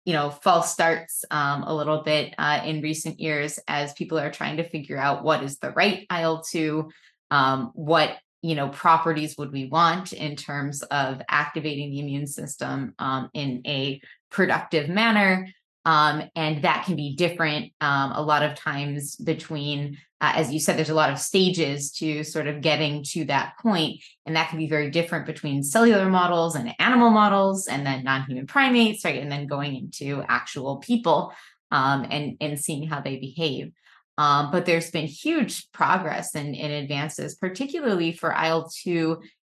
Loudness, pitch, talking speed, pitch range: -24 LUFS, 155 Hz, 170 wpm, 145-165 Hz